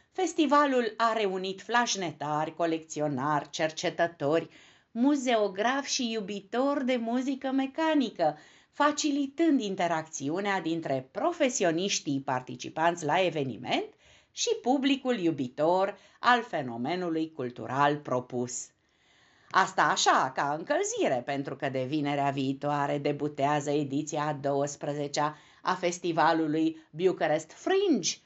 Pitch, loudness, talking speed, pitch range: 165 Hz, -29 LUFS, 90 wpm, 145-240 Hz